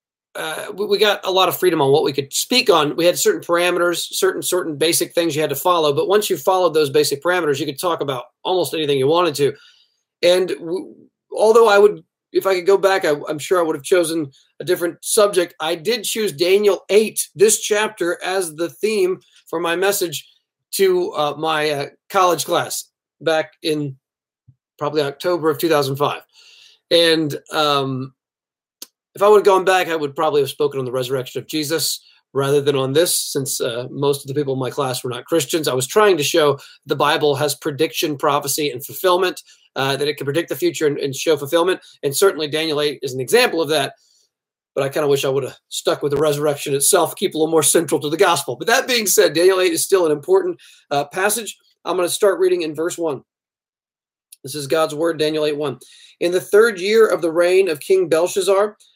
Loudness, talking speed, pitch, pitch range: -18 LUFS, 215 wpm, 165 Hz, 145-195 Hz